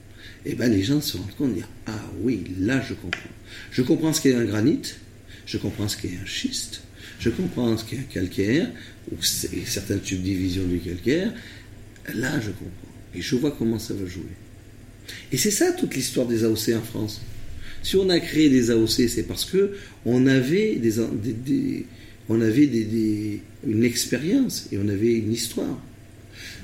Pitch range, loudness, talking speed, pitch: 100-125 Hz, -24 LUFS, 180 wpm, 110 Hz